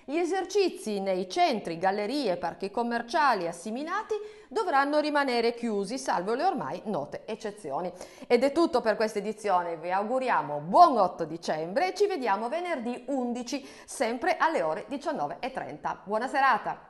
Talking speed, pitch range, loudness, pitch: 140 wpm, 190-300 Hz, -28 LUFS, 235 Hz